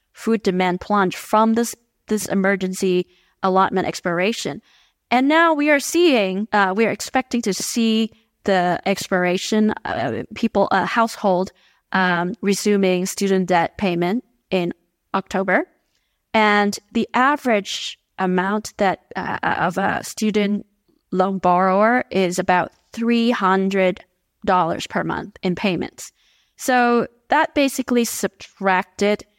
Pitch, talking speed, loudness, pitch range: 200 Hz, 120 wpm, -20 LUFS, 185-230 Hz